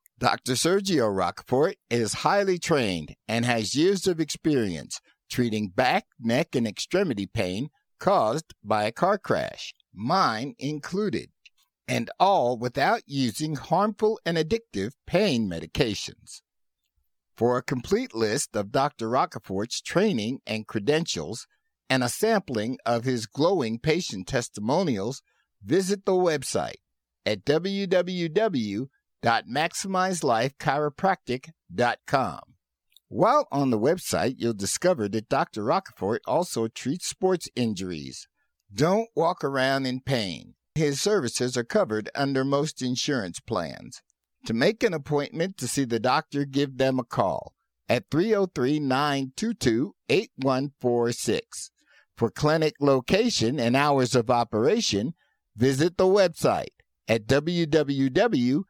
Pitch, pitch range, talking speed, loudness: 140 Hz, 120-170 Hz, 115 wpm, -26 LUFS